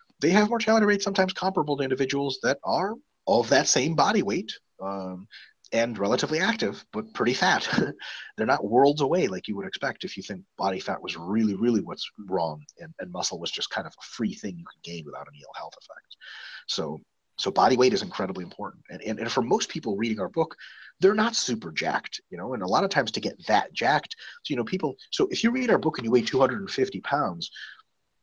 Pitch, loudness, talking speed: 140 Hz, -26 LUFS, 220 wpm